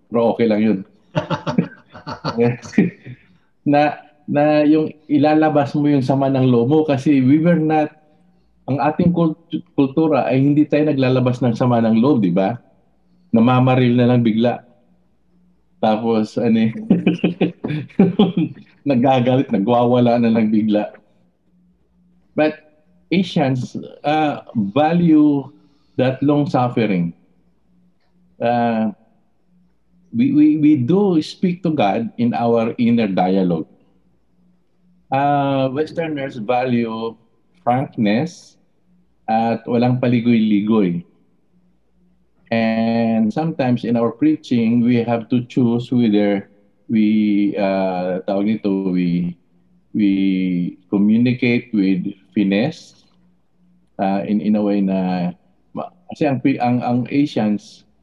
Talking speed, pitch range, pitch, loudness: 100 wpm, 110-155 Hz, 125 Hz, -17 LUFS